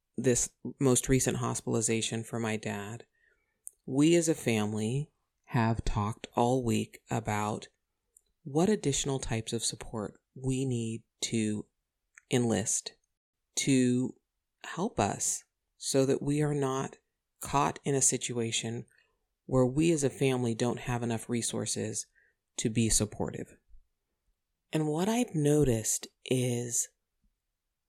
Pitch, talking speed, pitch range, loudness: 120 Hz, 115 wpm, 110-135 Hz, -30 LUFS